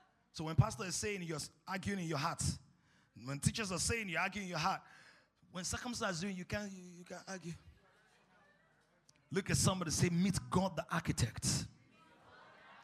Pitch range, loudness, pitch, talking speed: 155-190 Hz, -38 LUFS, 175 Hz, 165 wpm